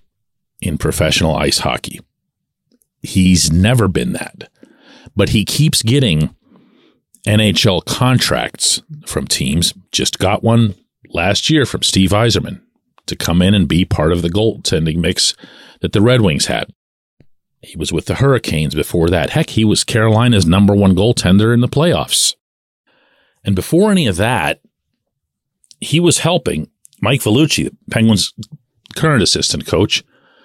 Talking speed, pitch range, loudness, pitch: 140 wpm, 90-125 Hz, -14 LUFS, 105 Hz